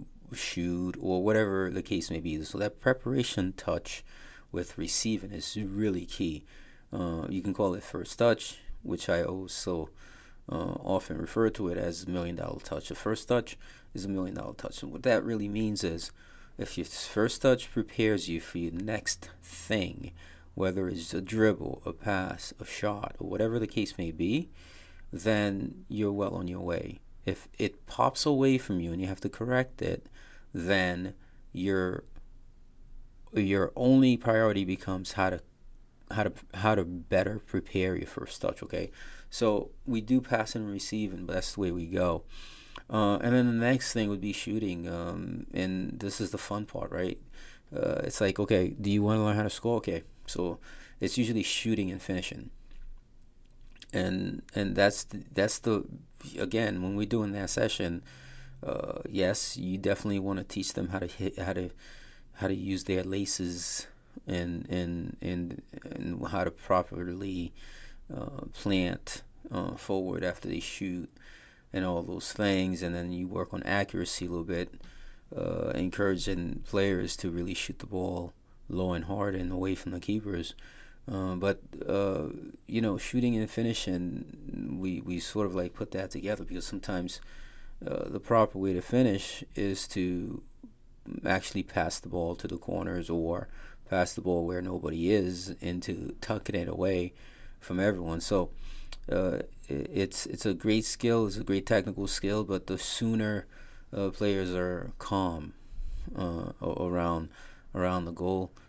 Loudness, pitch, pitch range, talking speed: -32 LUFS, 95 Hz, 90-105 Hz, 165 wpm